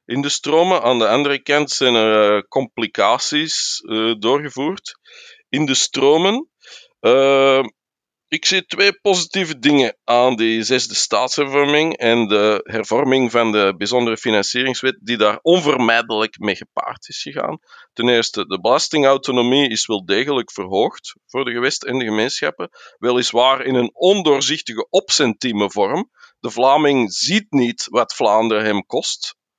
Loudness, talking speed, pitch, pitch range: -17 LUFS, 135 wpm, 130 Hz, 115-150 Hz